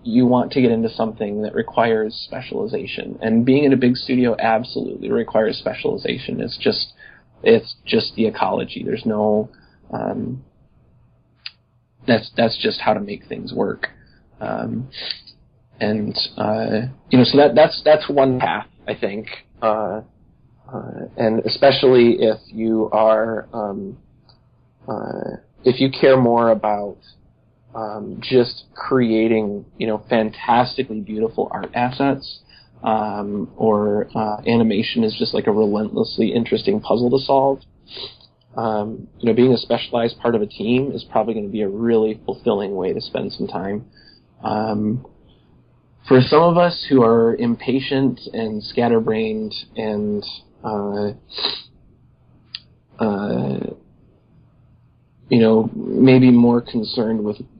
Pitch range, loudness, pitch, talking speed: 110-130 Hz, -19 LUFS, 115 Hz, 130 wpm